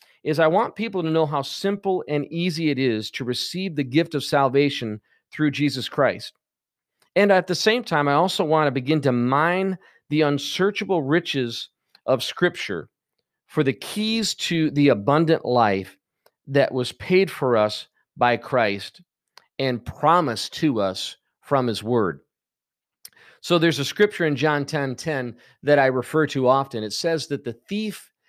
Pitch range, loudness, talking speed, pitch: 130-175 Hz, -22 LUFS, 165 wpm, 150 Hz